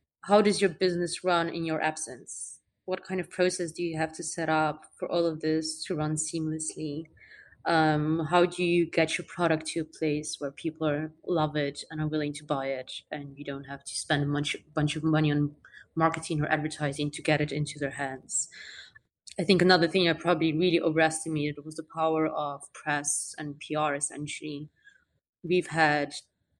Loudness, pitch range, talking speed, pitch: -28 LUFS, 150-170 Hz, 190 wpm, 155 Hz